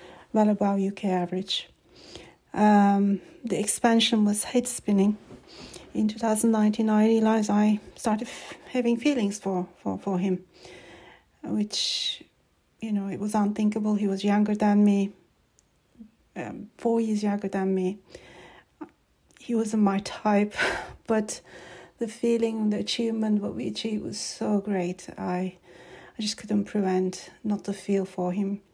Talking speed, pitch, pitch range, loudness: 135 wpm, 210 Hz, 195-220 Hz, -26 LUFS